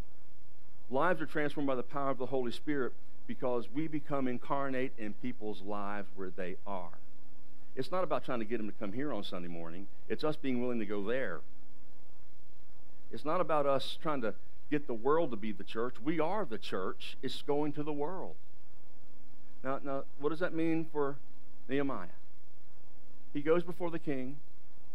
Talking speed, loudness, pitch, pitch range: 180 wpm, -37 LUFS, 130 Hz, 120-150 Hz